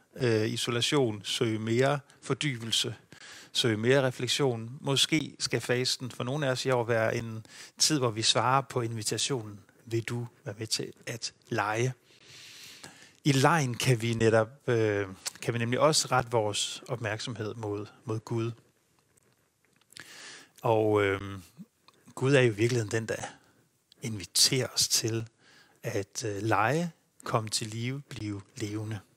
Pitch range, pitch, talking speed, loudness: 110-130 Hz, 120 Hz, 135 wpm, -29 LUFS